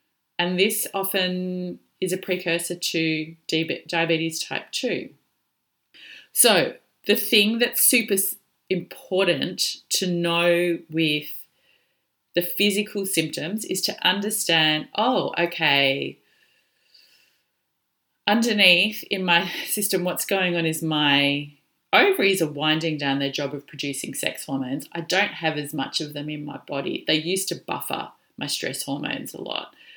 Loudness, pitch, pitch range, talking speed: -22 LUFS, 175 Hz, 155-190 Hz, 130 wpm